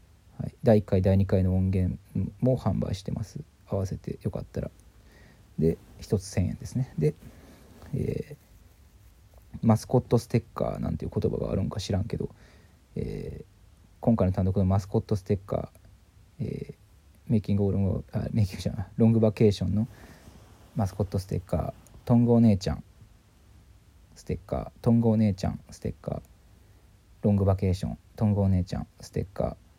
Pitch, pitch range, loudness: 100 Hz, 95-110 Hz, -28 LUFS